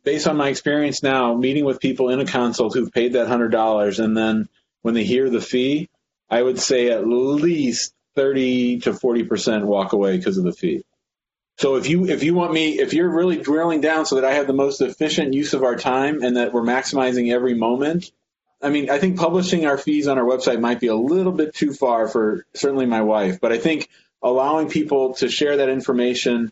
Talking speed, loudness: 215 wpm, -19 LUFS